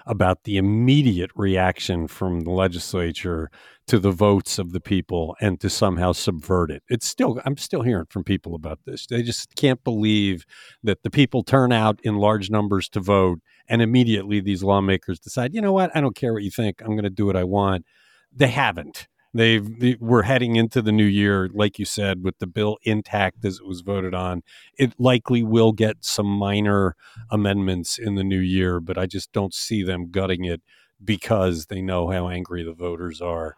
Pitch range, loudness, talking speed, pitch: 90-110 Hz, -22 LUFS, 200 wpm, 100 Hz